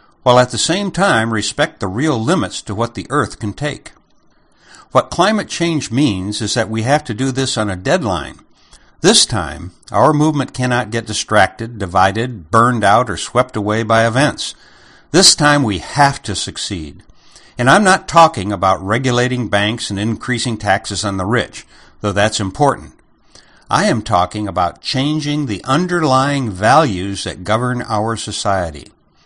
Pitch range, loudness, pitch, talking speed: 105-135 Hz, -15 LUFS, 115 Hz, 160 wpm